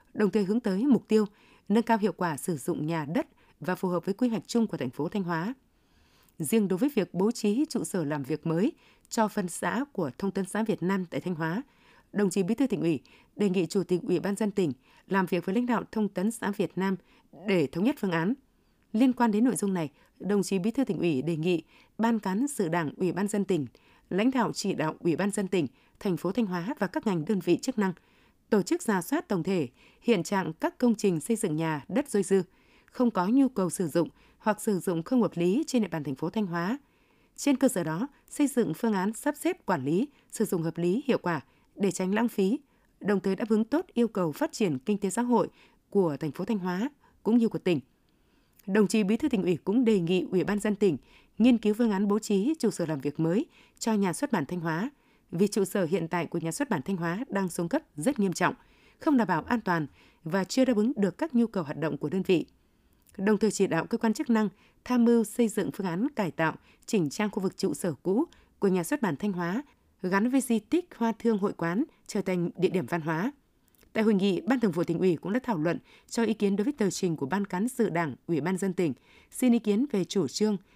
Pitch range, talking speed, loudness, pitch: 180-230 Hz, 255 wpm, -28 LUFS, 200 Hz